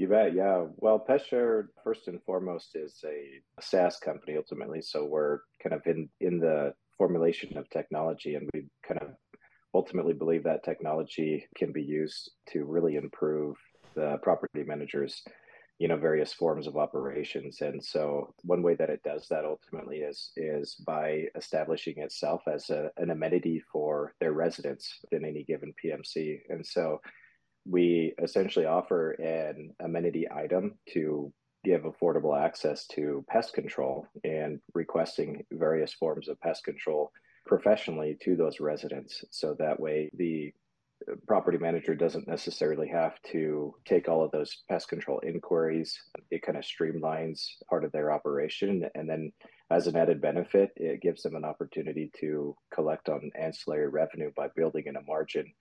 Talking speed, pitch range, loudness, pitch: 155 wpm, 75-85 Hz, -31 LUFS, 80 Hz